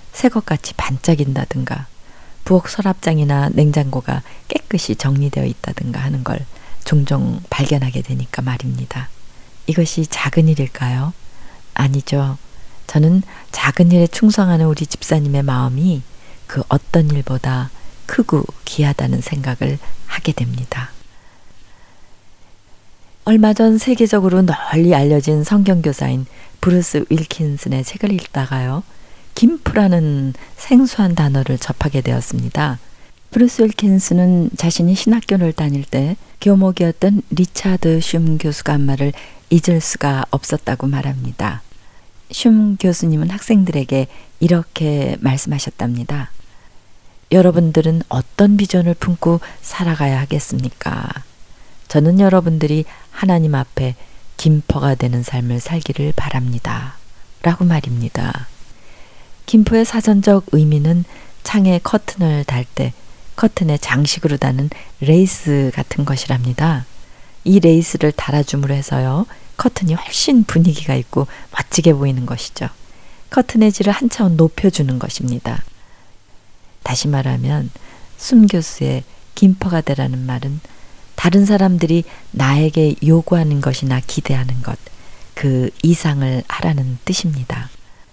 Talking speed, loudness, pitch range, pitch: 270 characters per minute, -16 LUFS, 130-175 Hz, 145 Hz